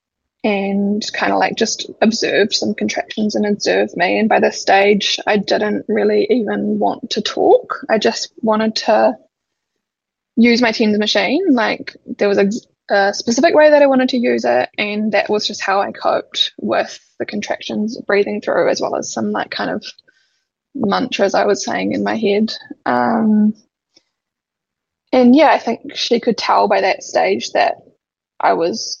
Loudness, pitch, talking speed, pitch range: -16 LUFS, 215 Hz, 170 wpm, 205-255 Hz